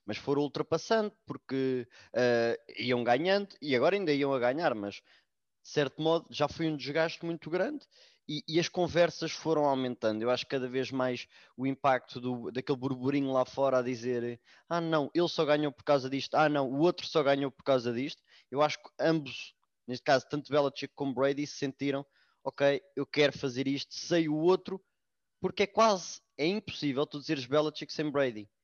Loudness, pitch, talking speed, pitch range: -31 LUFS, 140 Hz, 190 wpm, 130-160 Hz